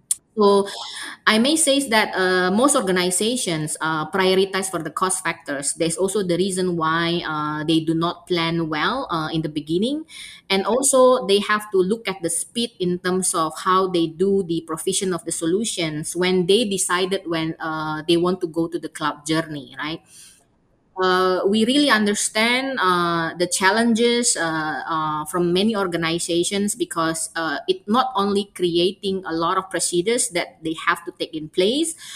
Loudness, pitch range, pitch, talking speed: -20 LUFS, 165-200 Hz, 180 Hz, 175 wpm